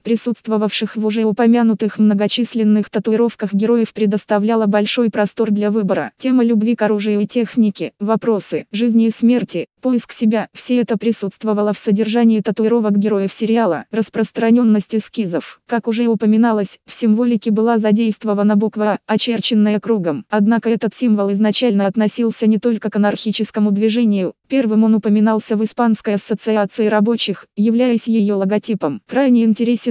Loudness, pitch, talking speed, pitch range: -16 LUFS, 220 Hz, 135 wpm, 210-230 Hz